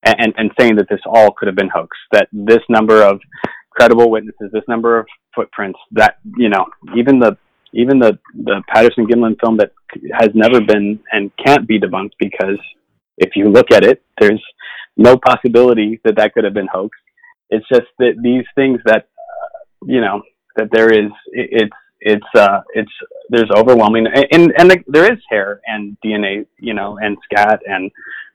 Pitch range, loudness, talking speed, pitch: 105-135 Hz, -12 LUFS, 180 wpm, 115 Hz